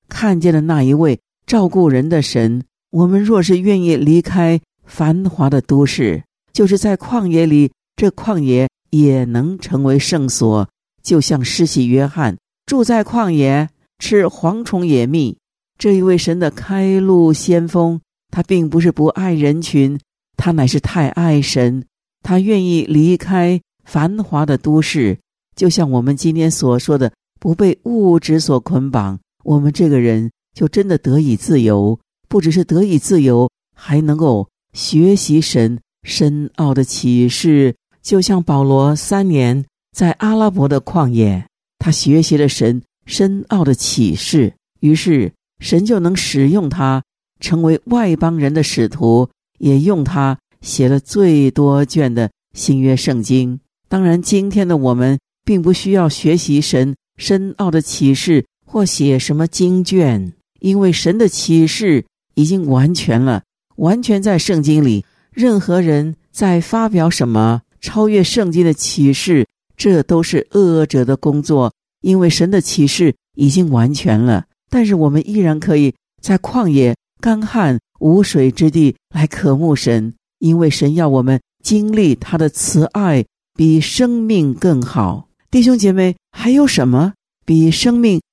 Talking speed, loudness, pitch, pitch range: 210 characters per minute, -14 LUFS, 160 Hz, 135-185 Hz